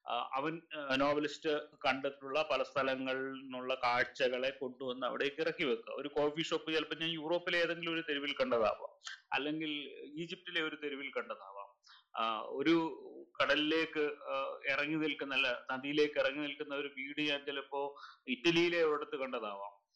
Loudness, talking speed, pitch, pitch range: -36 LUFS, 115 wpm, 150 Hz, 135-160 Hz